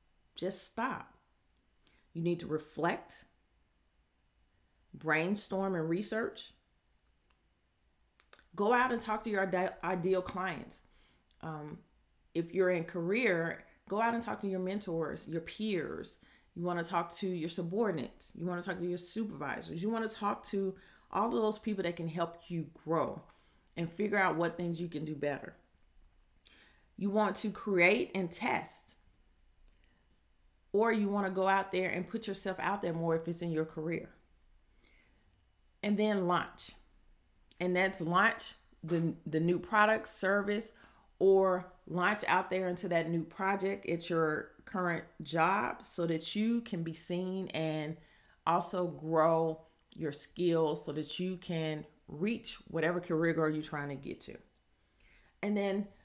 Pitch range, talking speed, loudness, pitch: 160-195 Hz, 150 wpm, -34 LUFS, 175 Hz